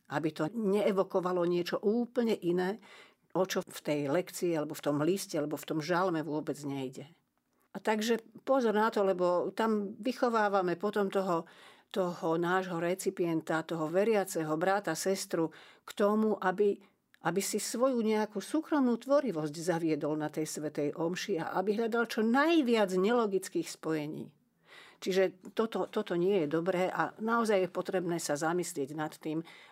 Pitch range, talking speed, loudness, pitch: 165-210 Hz, 145 wpm, -32 LUFS, 185 Hz